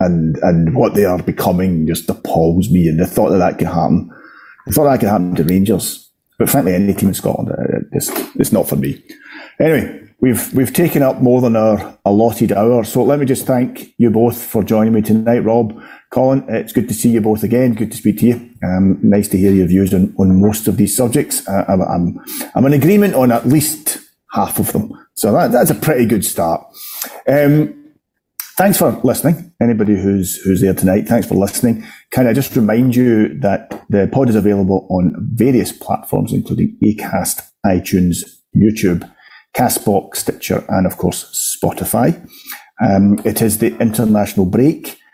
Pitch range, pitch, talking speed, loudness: 95-125 Hz, 110 Hz, 190 wpm, -14 LUFS